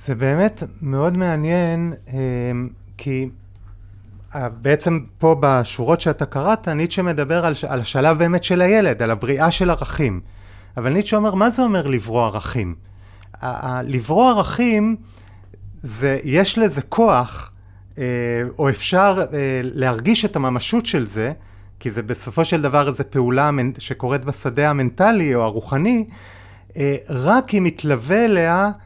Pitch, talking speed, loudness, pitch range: 140 Hz, 125 wpm, -19 LUFS, 120-170 Hz